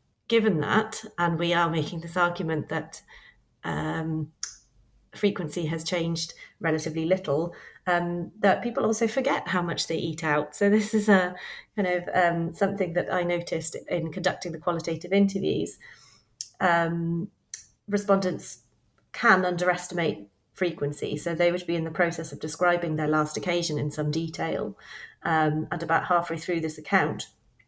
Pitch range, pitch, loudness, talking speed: 160-185 Hz, 170 Hz, -26 LUFS, 145 wpm